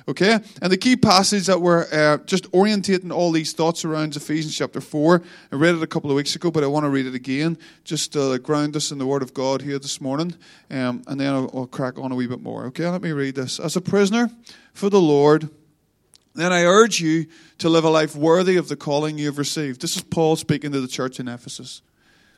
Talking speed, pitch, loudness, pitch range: 240 wpm, 155 Hz, -20 LUFS, 140-175 Hz